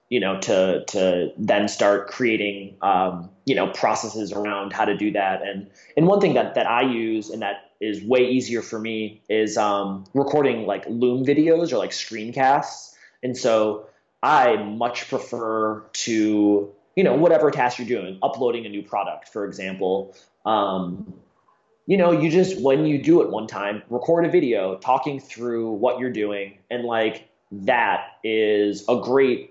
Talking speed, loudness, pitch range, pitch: 170 wpm, -22 LUFS, 100-125 Hz, 110 Hz